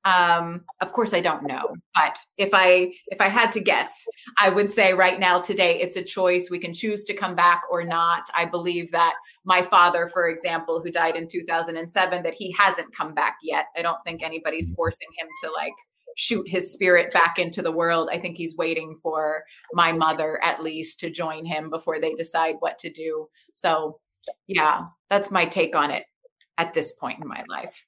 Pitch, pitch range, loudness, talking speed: 175 Hz, 165-195 Hz, -23 LUFS, 200 wpm